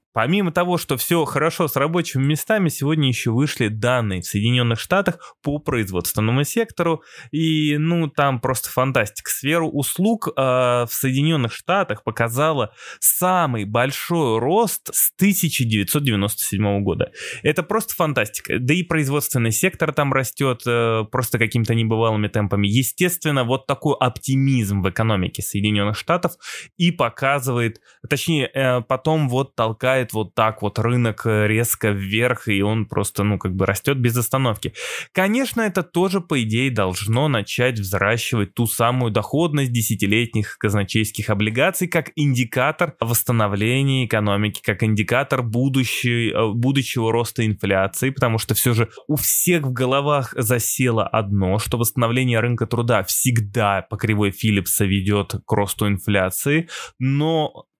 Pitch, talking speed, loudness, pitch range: 125 Hz, 130 wpm, -20 LUFS, 110-145 Hz